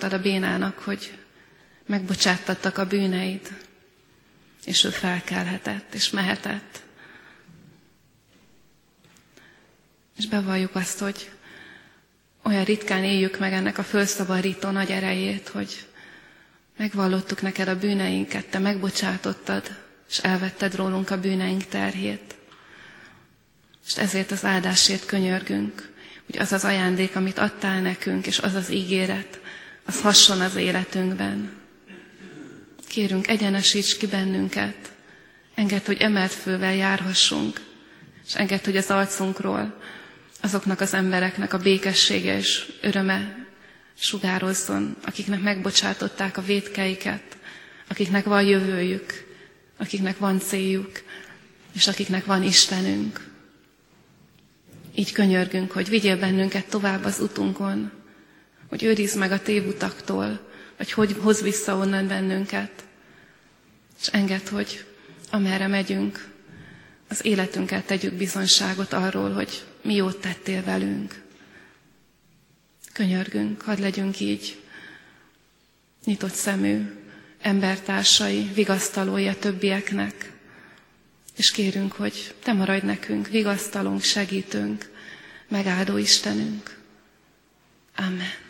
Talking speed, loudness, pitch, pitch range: 100 wpm, -23 LUFS, 190 Hz, 180-200 Hz